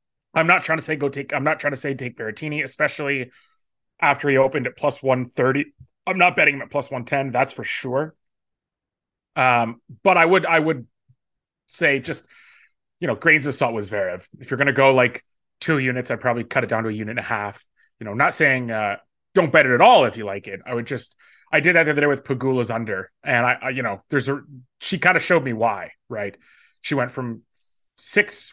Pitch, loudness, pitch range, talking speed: 135 Hz, -20 LUFS, 120-150 Hz, 235 wpm